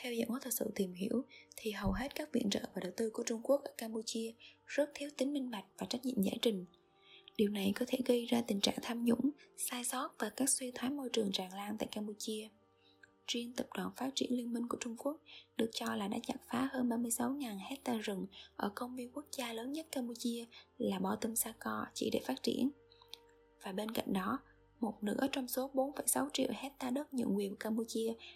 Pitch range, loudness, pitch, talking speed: 225-265 Hz, -38 LUFS, 245 Hz, 220 wpm